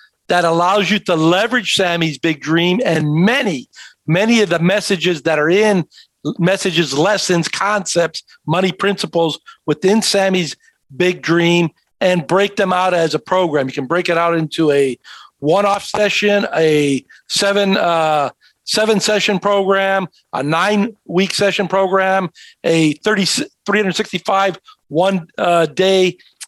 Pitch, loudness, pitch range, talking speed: 185 Hz, -15 LUFS, 165-200 Hz, 130 wpm